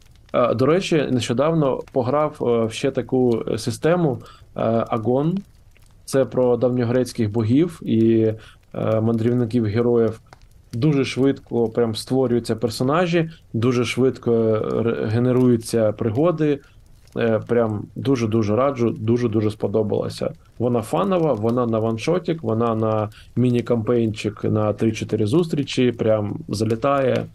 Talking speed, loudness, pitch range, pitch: 95 wpm, -21 LUFS, 110-130 Hz, 120 Hz